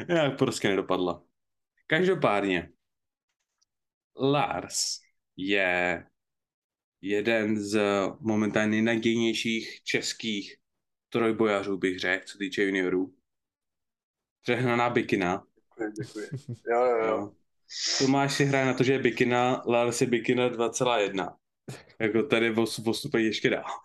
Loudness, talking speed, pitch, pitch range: -27 LUFS, 105 wpm, 110 Hz, 100-120 Hz